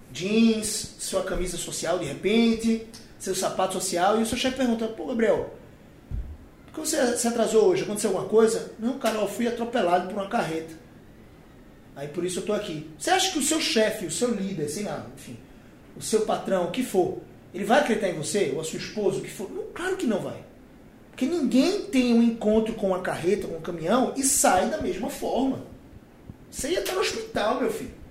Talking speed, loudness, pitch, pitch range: 205 wpm, -25 LUFS, 220 Hz, 185-250 Hz